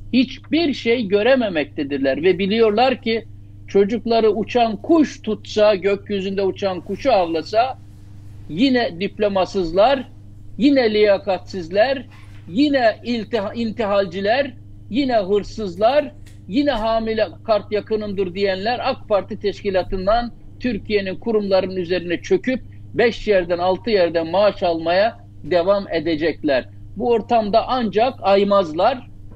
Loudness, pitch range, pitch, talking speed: -19 LUFS, 175-230 Hz, 200 Hz, 95 wpm